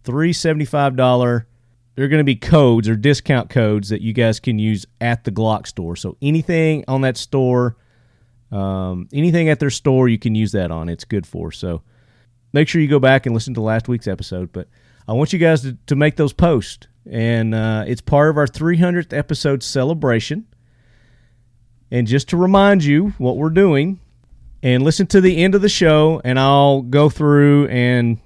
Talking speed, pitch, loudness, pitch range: 190 wpm, 125 Hz, -16 LUFS, 115-150 Hz